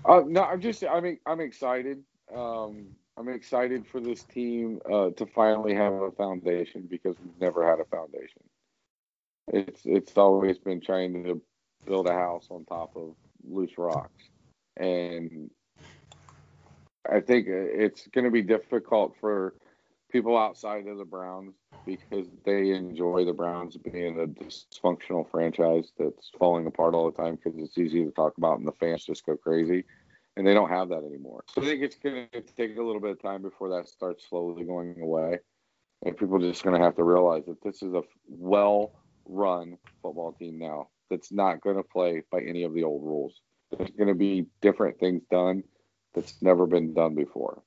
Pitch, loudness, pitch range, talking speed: 95 Hz, -28 LUFS, 85-110 Hz, 185 wpm